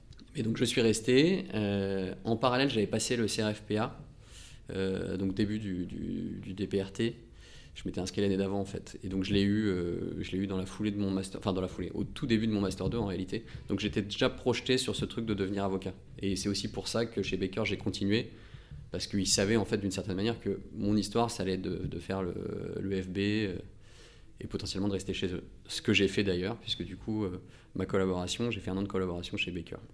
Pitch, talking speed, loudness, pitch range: 100 Hz, 240 wpm, -32 LUFS, 95-110 Hz